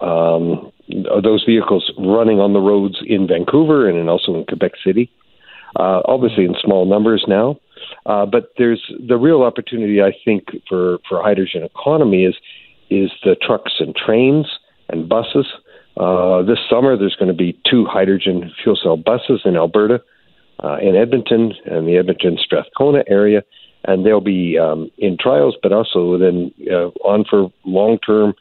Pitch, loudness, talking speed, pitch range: 100 Hz, -15 LUFS, 160 wpm, 90-110 Hz